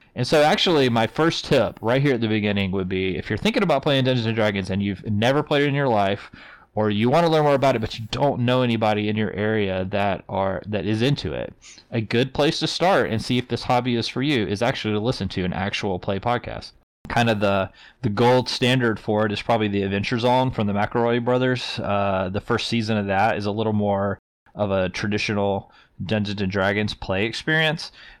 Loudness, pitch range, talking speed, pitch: -22 LUFS, 100-125 Hz, 230 wpm, 110 Hz